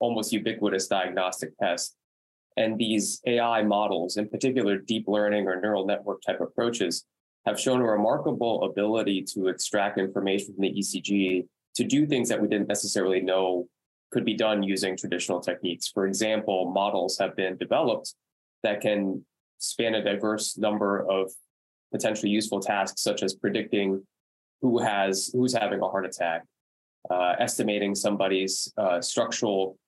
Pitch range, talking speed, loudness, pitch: 95-110 Hz, 145 wpm, -27 LUFS, 100 Hz